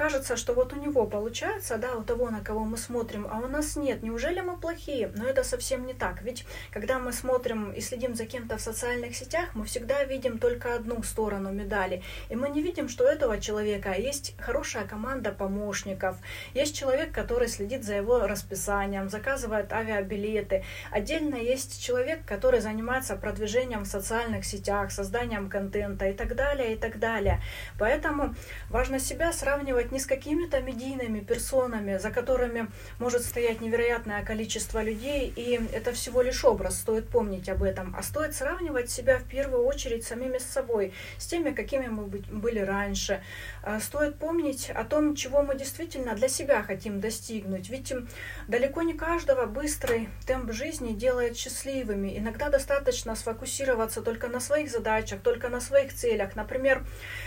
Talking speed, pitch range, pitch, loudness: 160 wpm, 215-275 Hz, 245 Hz, -29 LUFS